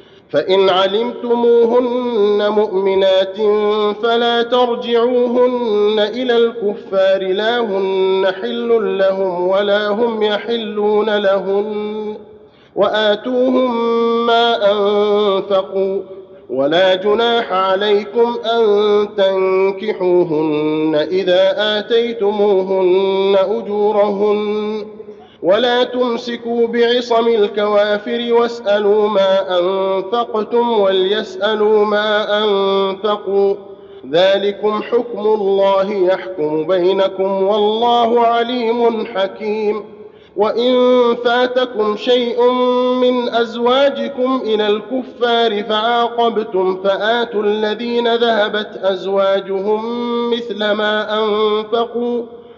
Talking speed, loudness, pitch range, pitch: 65 wpm, -15 LUFS, 195-235 Hz, 210 Hz